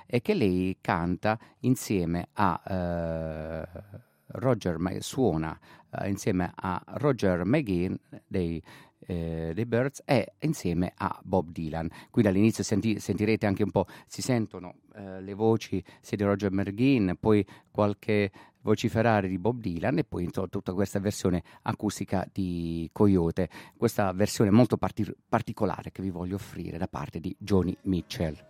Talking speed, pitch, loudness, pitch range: 145 wpm, 100 Hz, -29 LUFS, 90-110 Hz